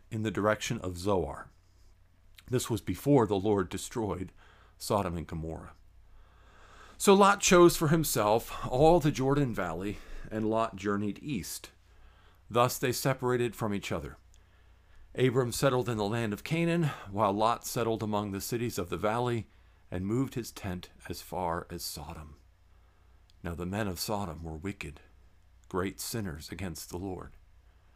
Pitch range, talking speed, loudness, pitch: 90-115 Hz, 150 wpm, -30 LUFS, 100 Hz